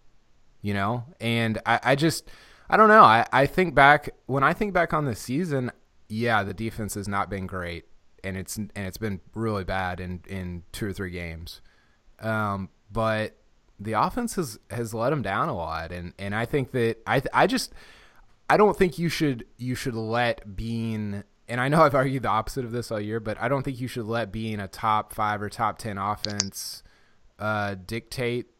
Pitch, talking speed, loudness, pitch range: 110 Hz, 200 wpm, -25 LUFS, 100-125 Hz